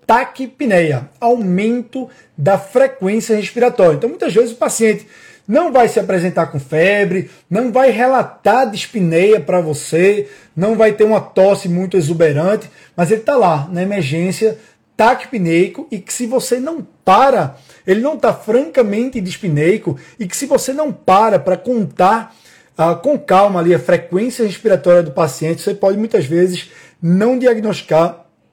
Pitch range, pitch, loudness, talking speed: 175-235 Hz, 200 Hz, -14 LUFS, 145 wpm